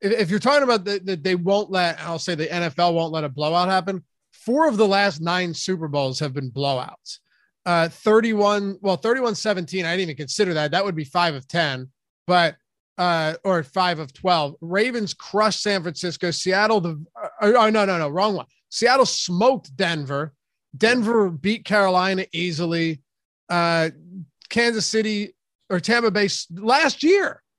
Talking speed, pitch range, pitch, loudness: 170 wpm, 165-210 Hz, 185 Hz, -21 LUFS